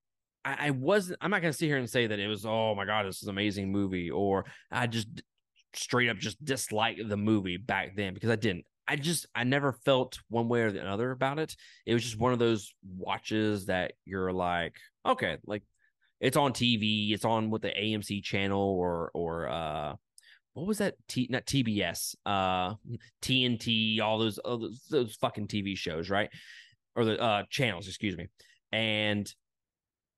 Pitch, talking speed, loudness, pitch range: 110 Hz, 185 wpm, -31 LUFS, 100-120 Hz